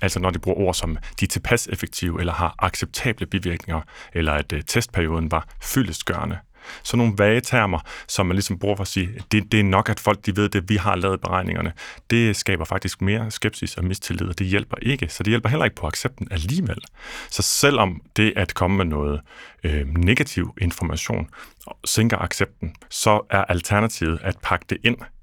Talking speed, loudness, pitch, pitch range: 195 wpm, -22 LUFS, 95 Hz, 85-110 Hz